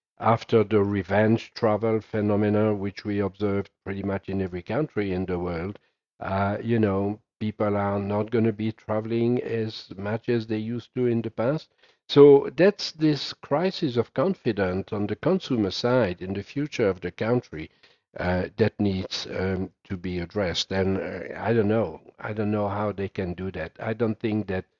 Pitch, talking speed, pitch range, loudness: 105 Hz, 180 wpm, 95-115 Hz, -25 LUFS